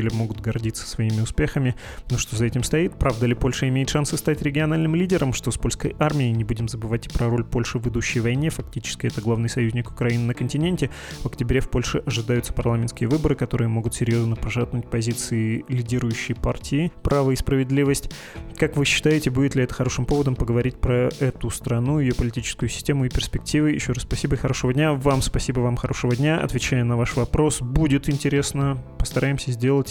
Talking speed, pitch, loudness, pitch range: 185 wpm, 125 Hz, -23 LUFS, 120-140 Hz